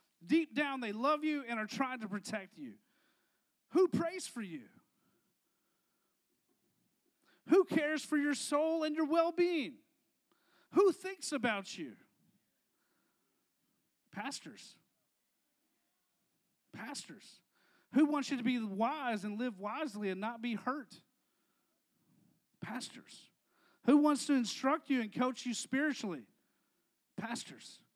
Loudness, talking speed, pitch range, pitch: -35 LUFS, 115 wpm, 235-310 Hz, 275 Hz